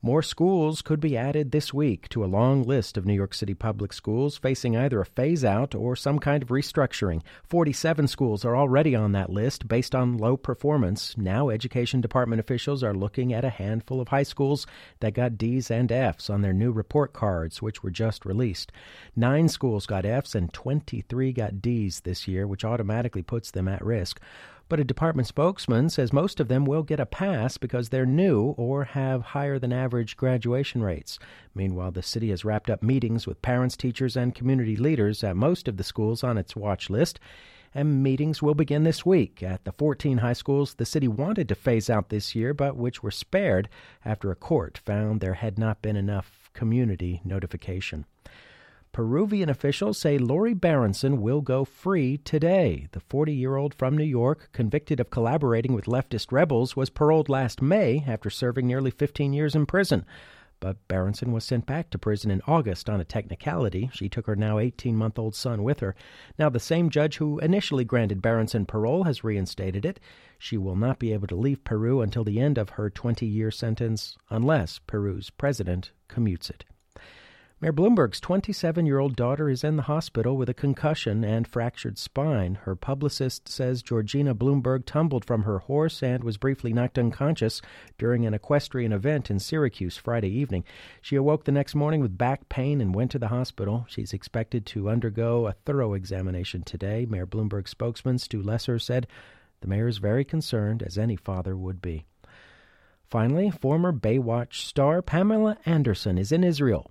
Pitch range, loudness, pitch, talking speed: 105-140 Hz, -26 LUFS, 120 Hz, 185 wpm